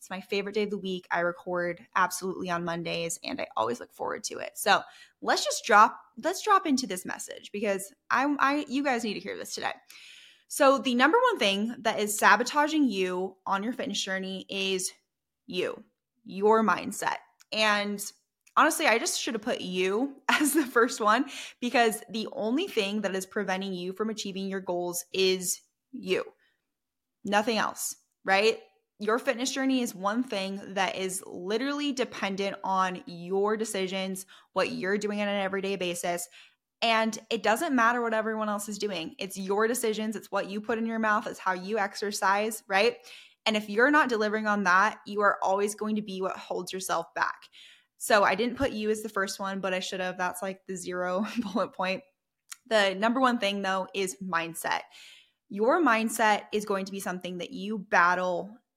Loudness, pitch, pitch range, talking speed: -28 LUFS, 205 Hz, 190-230 Hz, 185 wpm